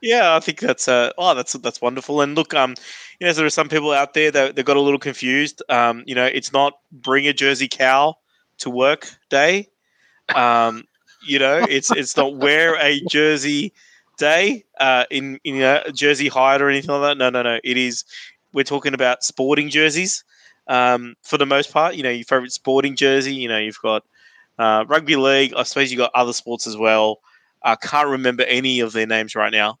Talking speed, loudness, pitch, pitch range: 210 wpm, -18 LUFS, 135 Hz, 125-145 Hz